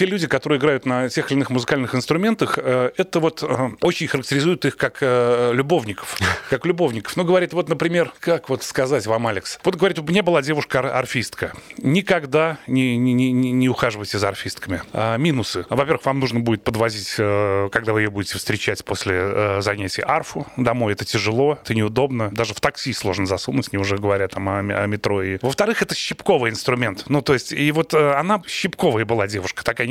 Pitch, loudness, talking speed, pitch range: 125 Hz, -20 LUFS, 180 wpm, 110-155 Hz